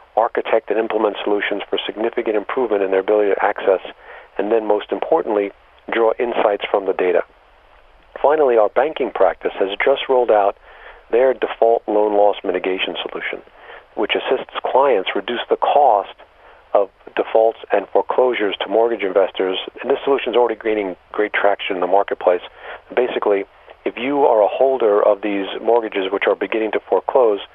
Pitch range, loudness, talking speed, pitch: 100-115 Hz, -18 LUFS, 160 wpm, 105 Hz